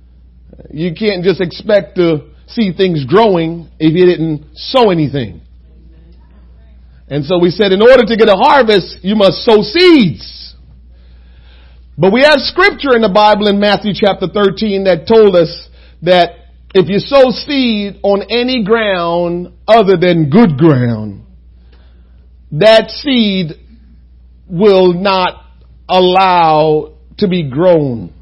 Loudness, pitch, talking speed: -10 LUFS, 180 Hz, 130 wpm